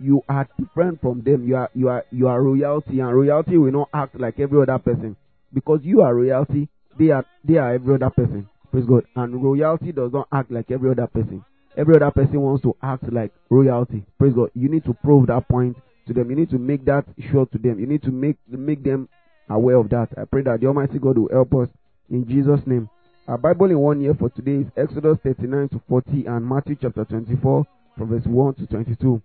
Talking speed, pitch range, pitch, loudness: 235 wpm, 125-145 Hz, 130 Hz, -20 LUFS